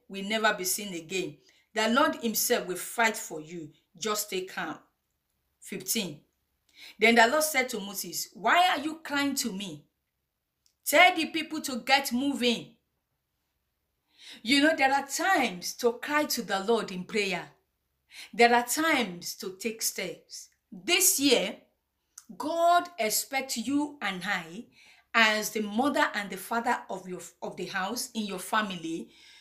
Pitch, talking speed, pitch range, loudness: 220 Hz, 150 wpm, 185-275 Hz, -27 LUFS